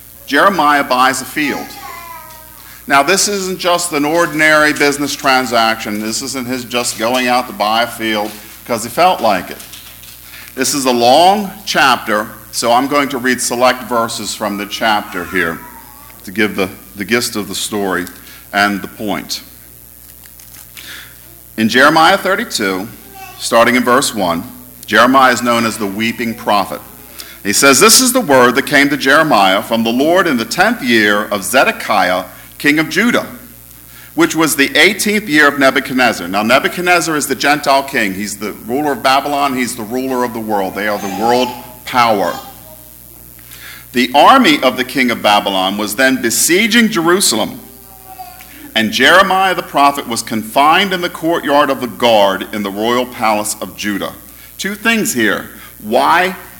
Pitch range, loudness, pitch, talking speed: 105-145 Hz, -12 LUFS, 125 Hz, 160 wpm